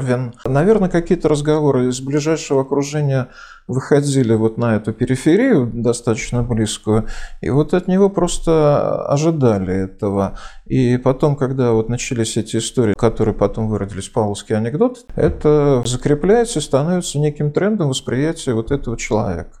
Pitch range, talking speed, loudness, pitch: 115-150 Hz, 130 wpm, -17 LUFS, 130 Hz